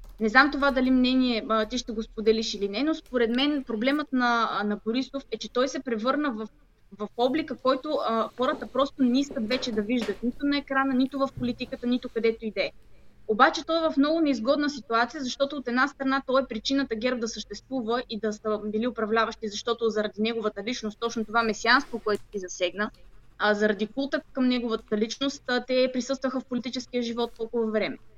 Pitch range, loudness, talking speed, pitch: 220-265 Hz, -27 LUFS, 190 wpm, 245 Hz